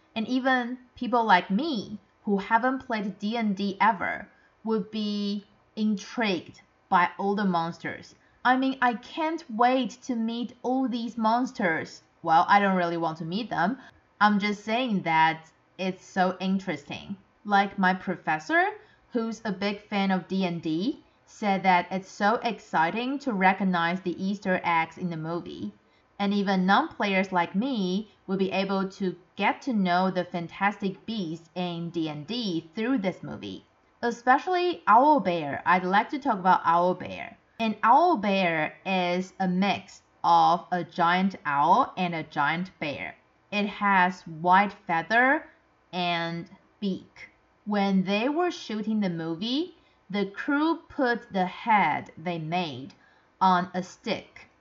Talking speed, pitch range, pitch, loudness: 145 wpm, 180-230 Hz, 195 Hz, -26 LUFS